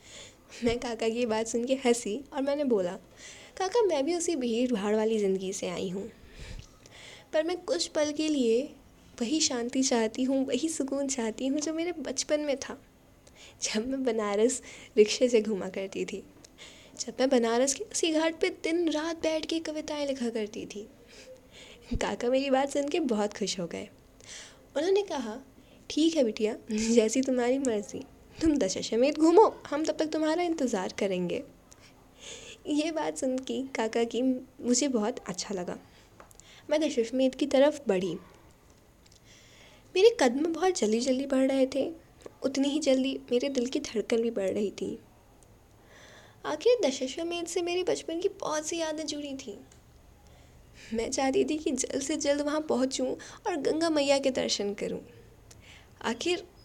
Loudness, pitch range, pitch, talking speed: -29 LUFS, 230-310 Hz, 265 Hz, 160 wpm